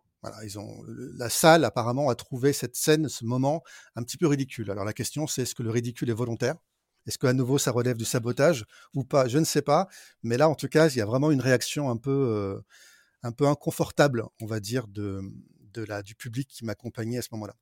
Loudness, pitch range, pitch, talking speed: -26 LUFS, 115-140 Hz, 125 Hz, 240 wpm